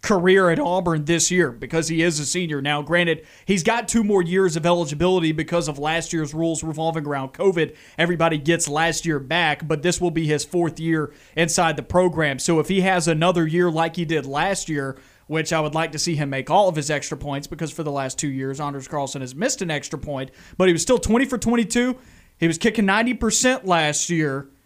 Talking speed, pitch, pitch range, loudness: 225 wpm, 165 Hz, 150-180 Hz, -21 LUFS